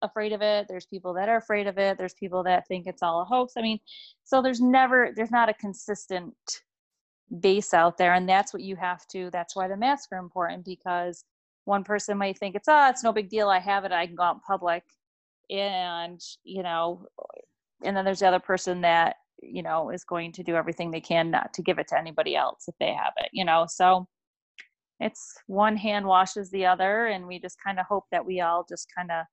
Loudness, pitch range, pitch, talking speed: -26 LUFS, 180-210 Hz, 190 Hz, 235 wpm